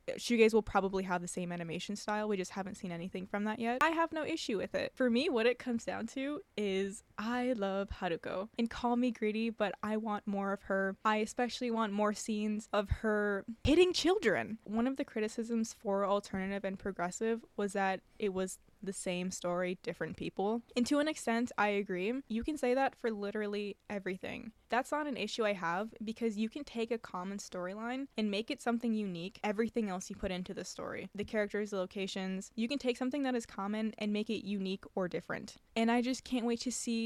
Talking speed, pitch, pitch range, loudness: 210 wpm, 215 Hz, 195-240 Hz, -35 LUFS